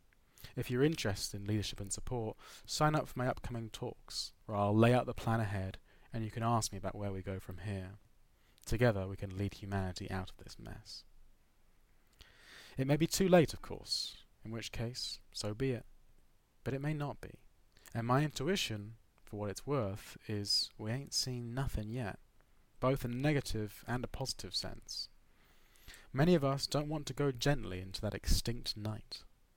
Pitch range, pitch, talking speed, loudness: 100-130 Hz, 115 Hz, 185 wpm, -36 LUFS